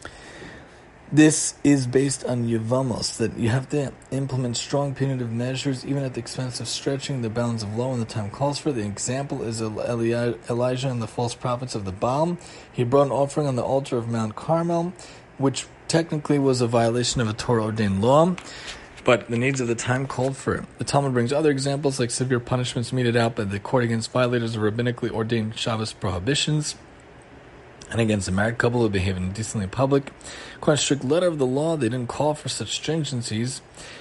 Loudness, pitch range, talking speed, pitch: -24 LUFS, 115-140 Hz, 190 wpm, 125 Hz